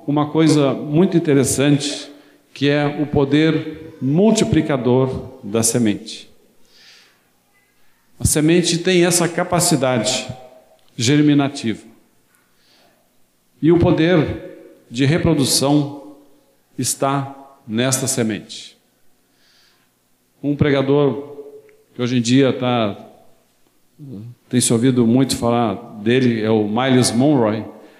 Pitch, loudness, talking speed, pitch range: 135 Hz, -17 LUFS, 90 wpm, 120-150 Hz